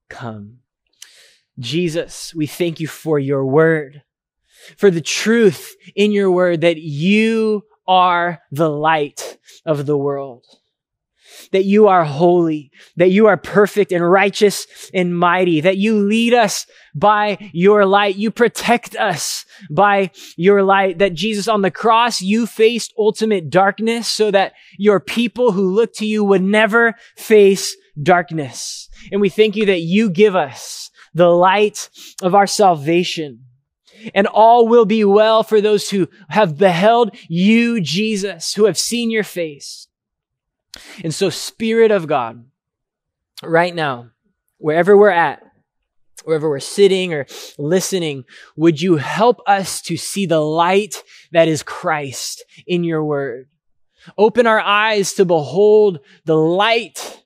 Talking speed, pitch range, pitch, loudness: 140 wpm, 165-215 Hz, 190 Hz, -15 LUFS